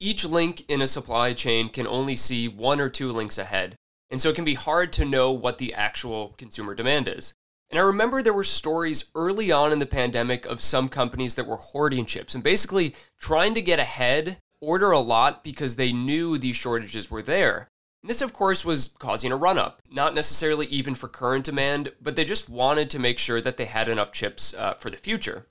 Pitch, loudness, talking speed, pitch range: 135 Hz, -24 LUFS, 220 wpm, 120-155 Hz